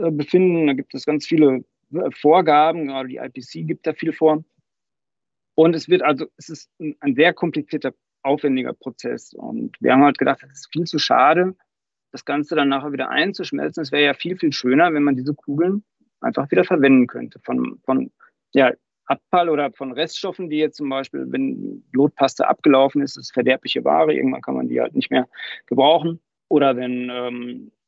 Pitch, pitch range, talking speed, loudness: 150 Hz, 135-165 Hz, 185 wpm, -19 LUFS